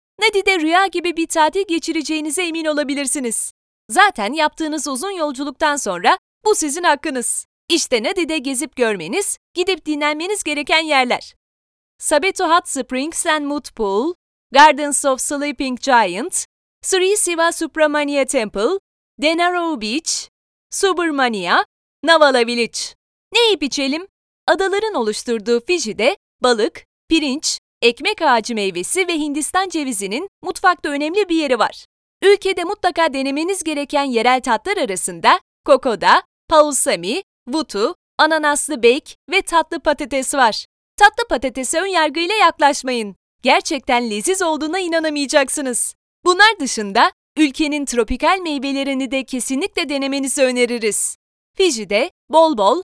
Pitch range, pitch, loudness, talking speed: 265-350 Hz, 305 Hz, -17 LUFS, 110 wpm